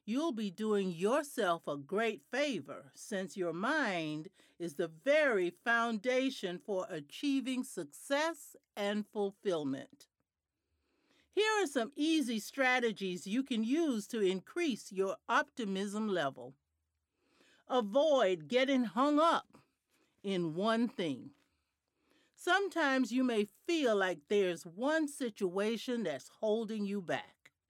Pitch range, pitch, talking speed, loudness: 190-275 Hz, 225 Hz, 110 wpm, -34 LUFS